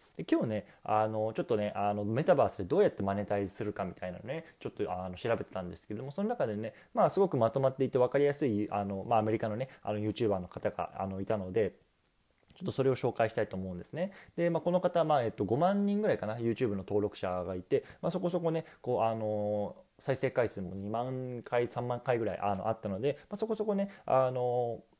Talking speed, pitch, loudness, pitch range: 470 characters per minute, 115 Hz, -33 LUFS, 105-140 Hz